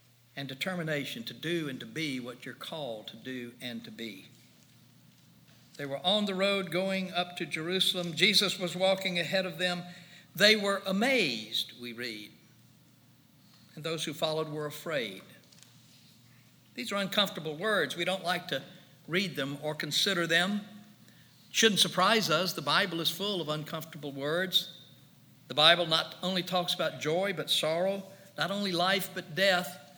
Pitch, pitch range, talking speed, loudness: 165 Hz, 140-185 Hz, 160 wpm, -29 LUFS